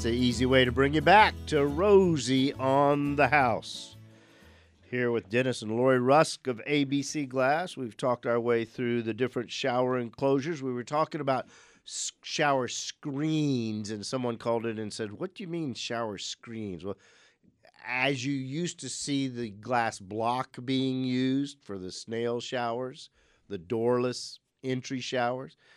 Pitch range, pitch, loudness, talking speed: 115-140 Hz, 125 Hz, -28 LUFS, 160 wpm